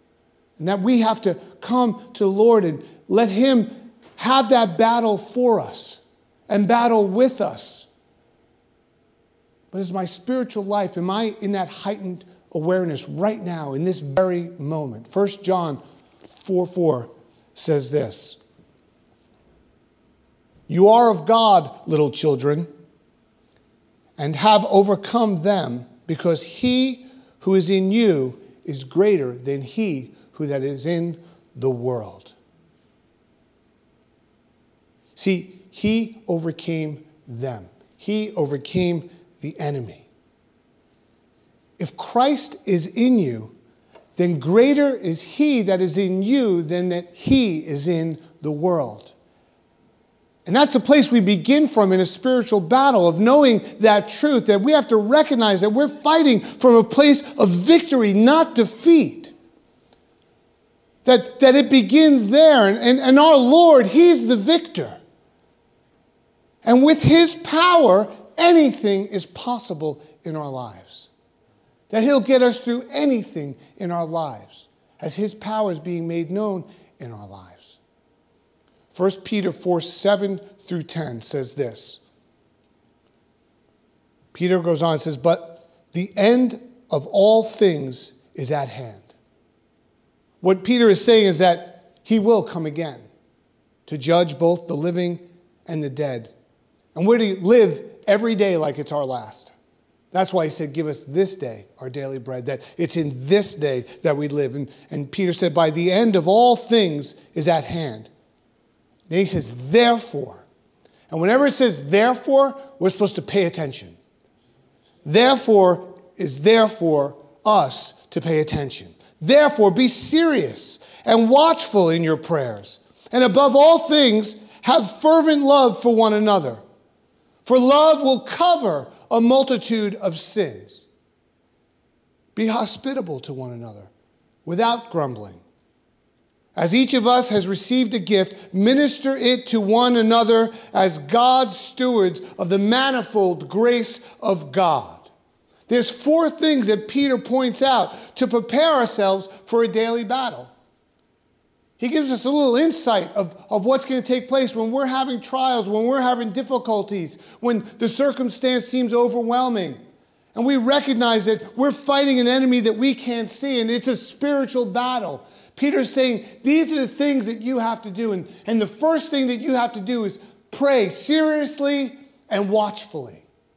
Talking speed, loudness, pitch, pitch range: 140 wpm, -19 LUFS, 205 Hz, 170-250 Hz